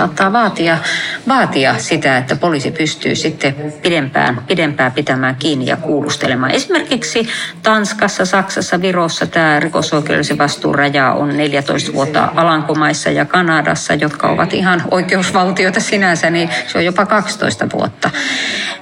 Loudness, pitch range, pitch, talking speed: -14 LUFS, 145-190 Hz, 165 Hz, 120 wpm